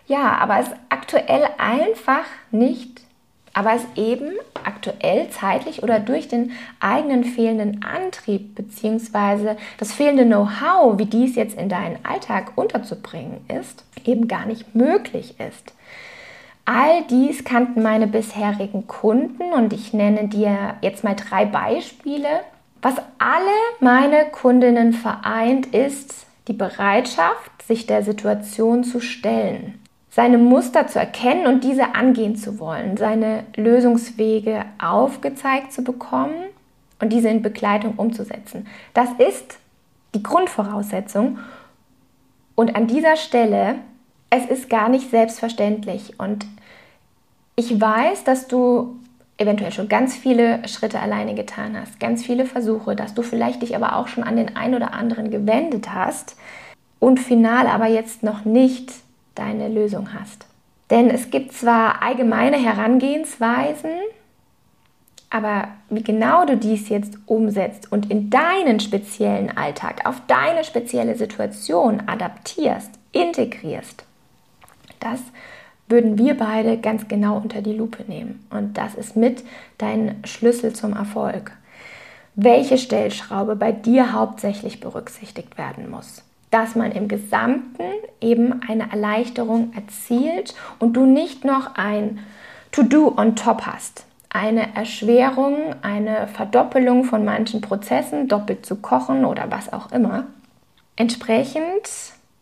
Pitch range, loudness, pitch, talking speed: 215-255 Hz, -19 LUFS, 230 Hz, 125 wpm